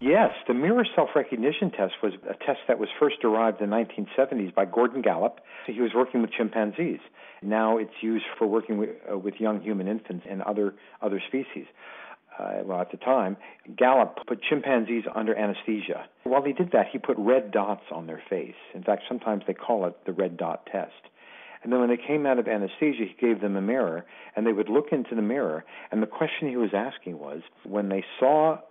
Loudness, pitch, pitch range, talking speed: -26 LUFS, 110 Hz, 105-125 Hz, 205 wpm